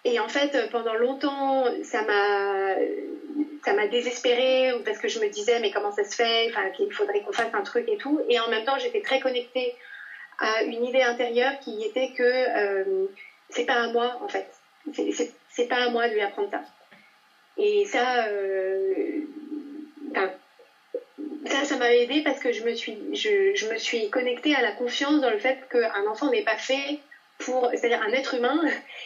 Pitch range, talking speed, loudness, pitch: 235-385 Hz, 190 wpm, -25 LUFS, 265 Hz